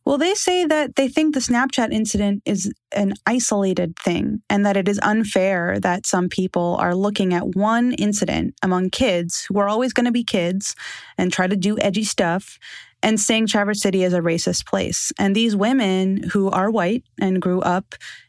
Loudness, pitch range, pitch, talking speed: -20 LUFS, 185-230 Hz, 205 Hz, 190 wpm